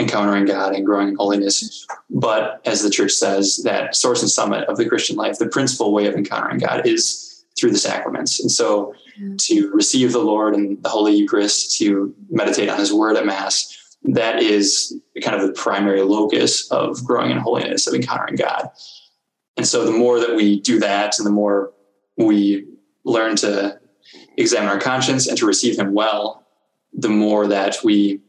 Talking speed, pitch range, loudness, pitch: 180 wpm, 100-125 Hz, -18 LUFS, 105 Hz